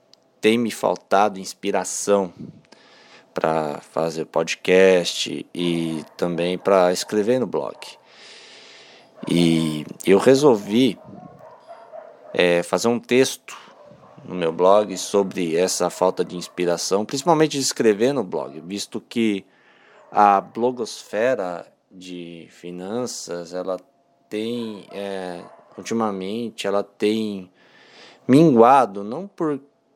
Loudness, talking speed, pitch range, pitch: -21 LUFS, 95 wpm, 90-115 Hz, 95 Hz